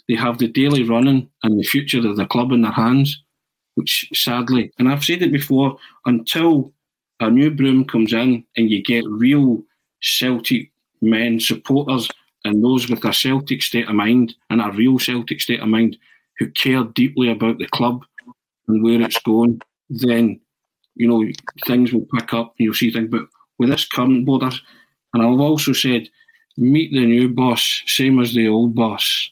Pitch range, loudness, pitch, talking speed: 115-130 Hz, -17 LUFS, 125 Hz, 180 wpm